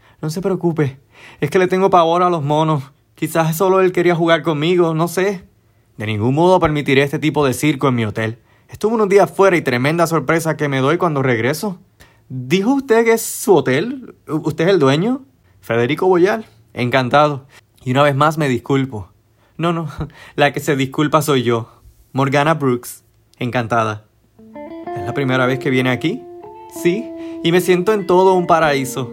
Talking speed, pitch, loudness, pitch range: 180 wpm, 150 Hz, -16 LUFS, 125-180 Hz